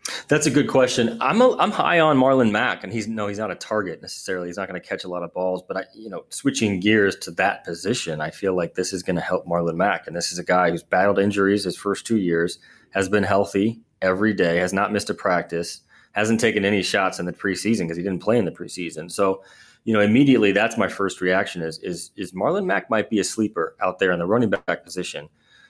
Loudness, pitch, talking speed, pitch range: -22 LUFS, 100 Hz, 250 wpm, 90-110 Hz